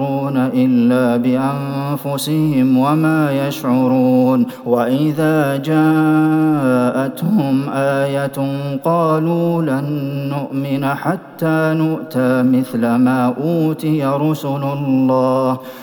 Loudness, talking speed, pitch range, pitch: -16 LUFS, 65 wpm, 130-155 Hz, 140 Hz